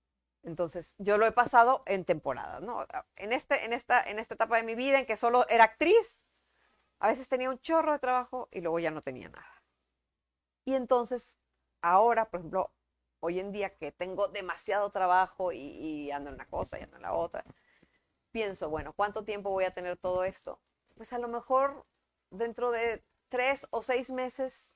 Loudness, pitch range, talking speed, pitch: -30 LUFS, 175-250 Hz, 190 wpm, 215 Hz